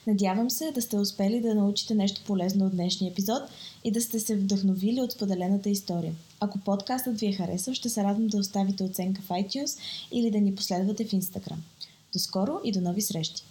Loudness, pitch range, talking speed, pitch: -28 LUFS, 185-220 Hz, 200 wpm, 200 Hz